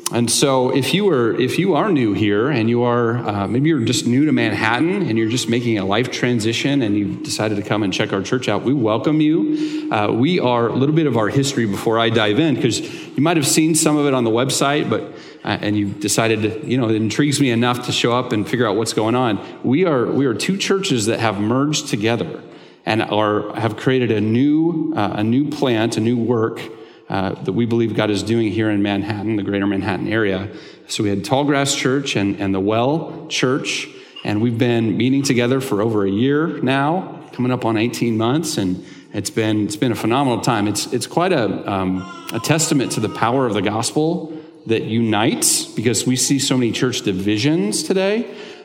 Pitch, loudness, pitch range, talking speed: 120 Hz, -18 LUFS, 105-140 Hz, 220 wpm